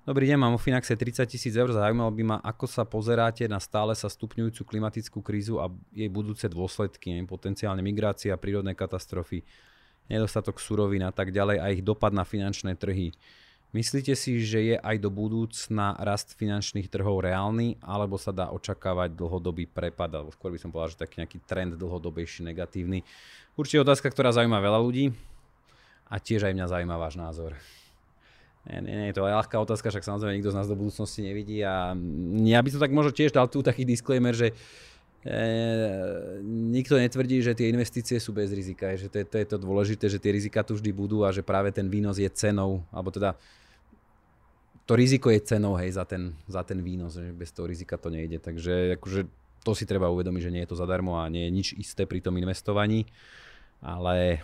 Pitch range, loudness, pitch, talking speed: 90-110 Hz, -28 LUFS, 100 Hz, 195 wpm